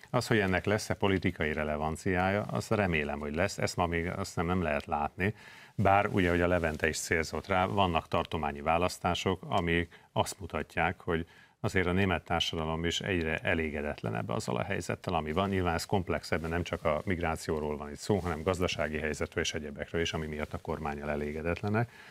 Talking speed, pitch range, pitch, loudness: 180 wpm, 80-95 Hz, 85 Hz, -31 LUFS